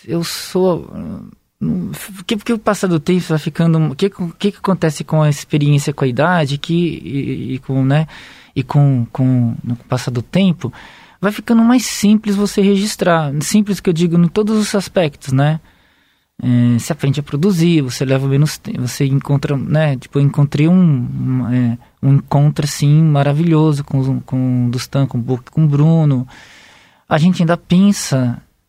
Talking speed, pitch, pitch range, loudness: 170 wpm, 155 Hz, 135-180 Hz, -15 LUFS